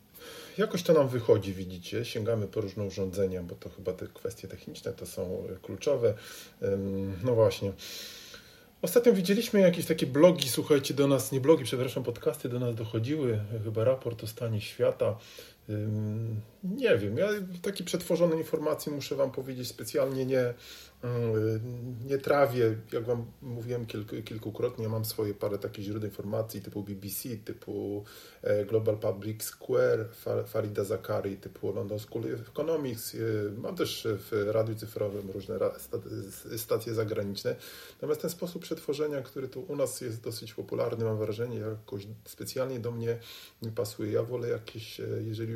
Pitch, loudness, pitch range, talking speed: 120 Hz, -31 LUFS, 110-155 Hz, 145 wpm